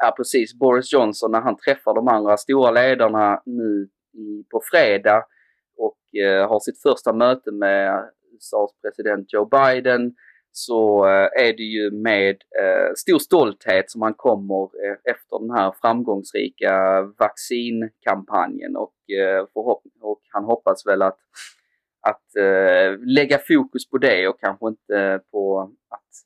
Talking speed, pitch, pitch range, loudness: 135 wpm, 105 Hz, 100-115 Hz, -19 LUFS